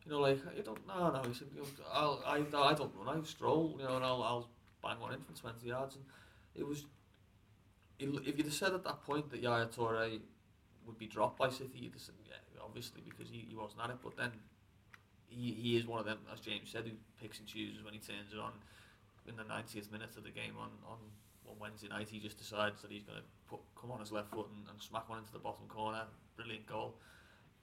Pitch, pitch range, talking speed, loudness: 110 Hz, 105-120 Hz, 240 wpm, -41 LUFS